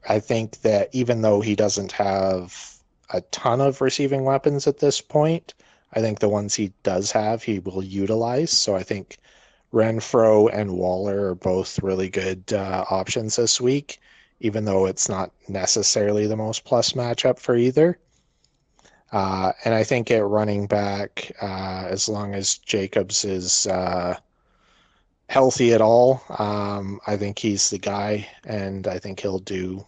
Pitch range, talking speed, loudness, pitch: 95-120 Hz, 160 wpm, -22 LUFS, 105 Hz